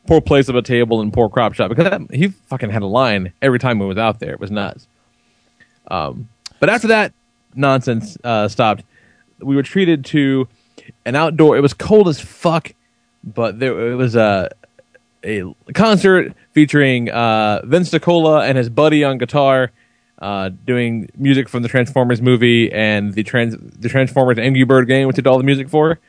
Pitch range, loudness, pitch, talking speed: 115-145 Hz, -15 LUFS, 130 Hz, 185 wpm